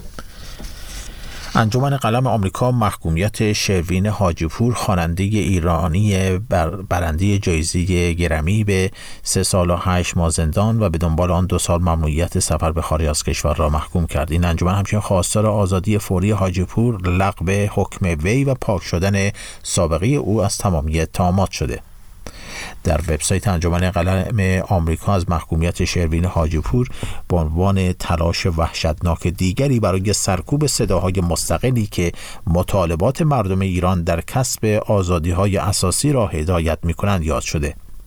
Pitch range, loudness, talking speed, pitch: 85-100 Hz, -19 LUFS, 135 wpm, 95 Hz